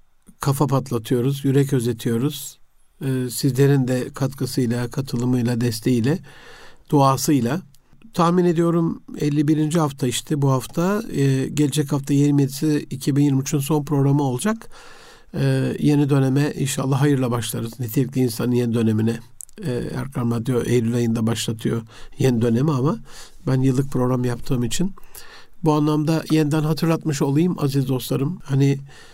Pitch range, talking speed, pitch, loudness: 125-150 Hz, 120 wpm, 140 Hz, -21 LUFS